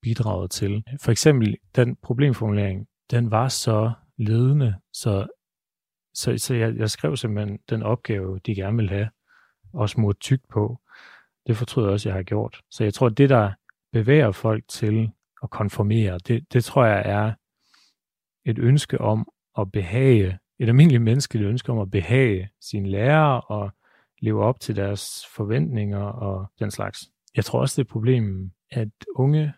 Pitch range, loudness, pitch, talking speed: 105-125 Hz, -23 LUFS, 110 Hz, 165 wpm